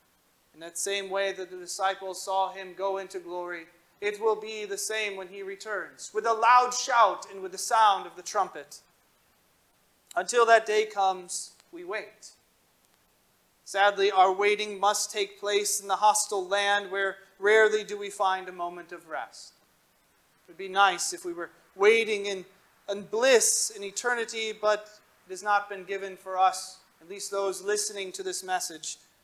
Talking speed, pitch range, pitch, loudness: 170 wpm, 190-210 Hz, 200 Hz, -27 LUFS